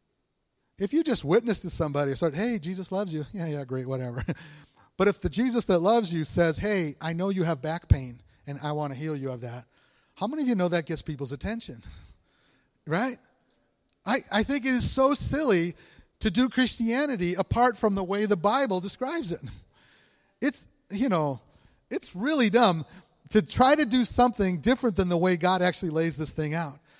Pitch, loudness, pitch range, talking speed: 185 Hz, -27 LUFS, 155-230 Hz, 195 wpm